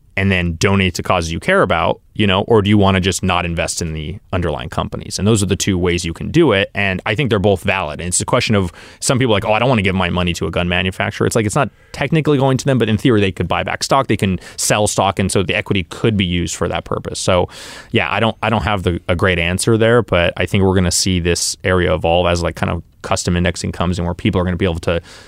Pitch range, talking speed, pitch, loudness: 90-105 Hz, 300 wpm, 95 Hz, -16 LUFS